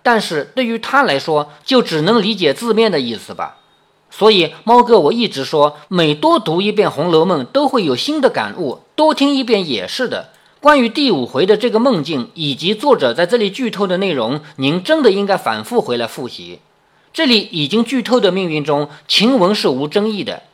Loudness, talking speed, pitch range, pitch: -15 LUFS, 285 characters per minute, 155-245 Hz, 210 Hz